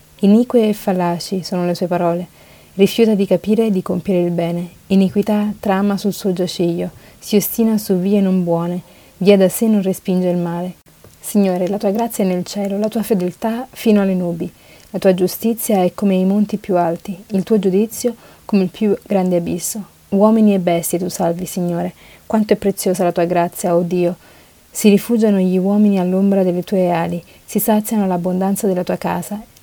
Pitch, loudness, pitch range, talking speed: 190 Hz, -17 LUFS, 180-210 Hz, 185 wpm